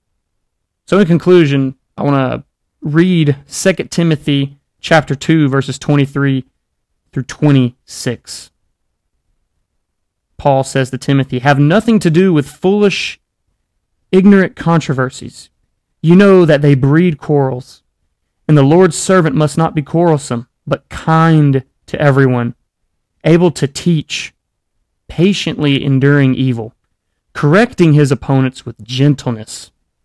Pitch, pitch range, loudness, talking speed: 140 Hz, 125-160 Hz, -12 LUFS, 110 wpm